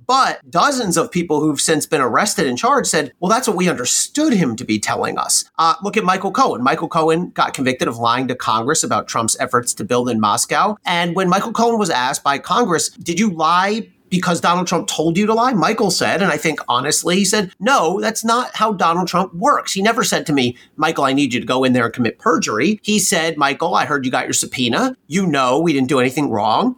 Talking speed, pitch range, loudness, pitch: 240 wpm, 145-215 Hz, -17 LUFS, 175 Hz